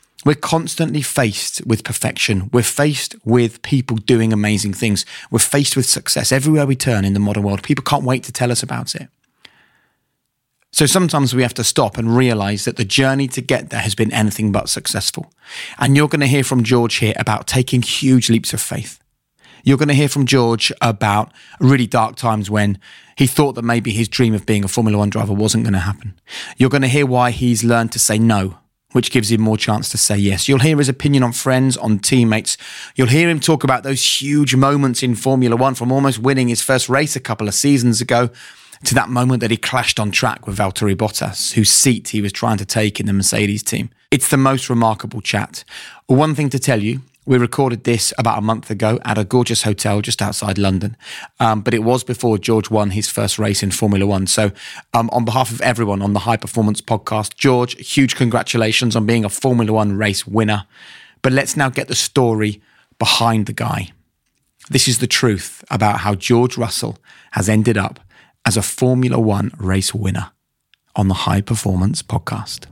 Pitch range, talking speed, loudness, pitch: 105-130 Hz, 205 wpm, -16 LUFS, 115 Hz